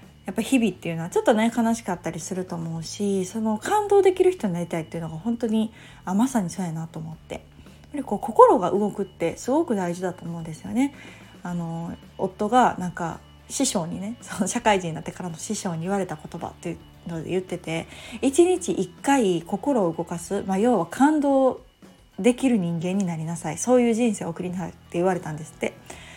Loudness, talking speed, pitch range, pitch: -24 LUFS, 350 characters per minute, 170-230 Hz, 190 Hz